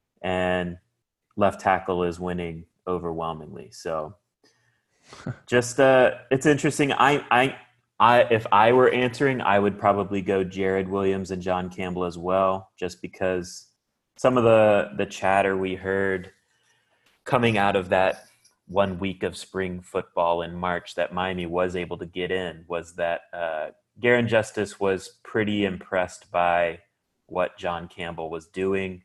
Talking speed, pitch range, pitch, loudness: 145 wpm, 90-100 Hz, 95 Hz, -24 LUFS